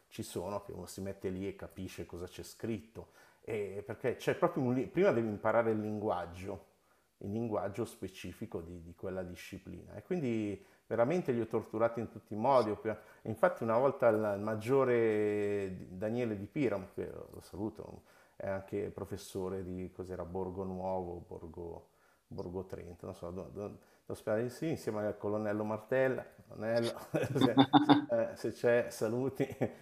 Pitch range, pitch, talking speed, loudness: 95-115 Hz, 105 Hz, 155 wpm, -35 LUFS